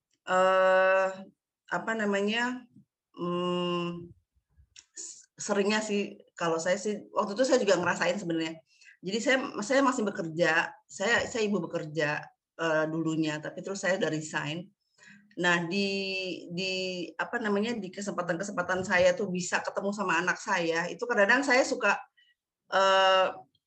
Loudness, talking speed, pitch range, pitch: -28 LUFS, 135 wpm, 170-205 Hz, 185 Hz